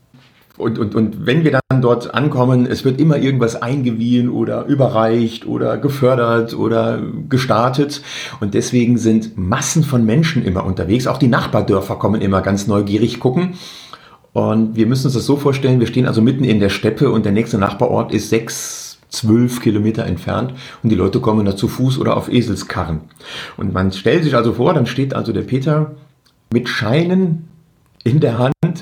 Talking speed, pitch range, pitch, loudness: 175 wpm, 110-130 Hz, 120 Hz, -16 LUFS